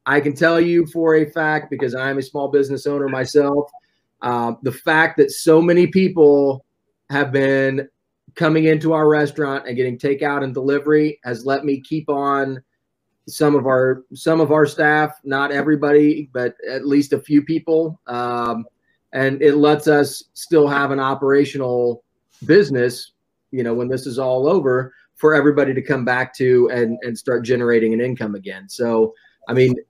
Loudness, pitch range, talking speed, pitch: -18 LUFS, 130-150 Hz, 170 wpm, 140 Hz